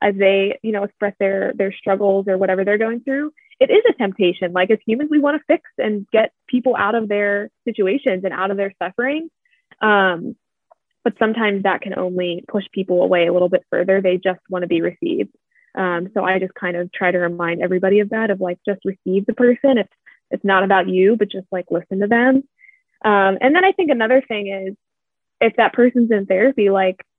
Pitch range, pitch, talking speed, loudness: 190-245 Hz, 200 Hz, 215 wpm, -18 LUFS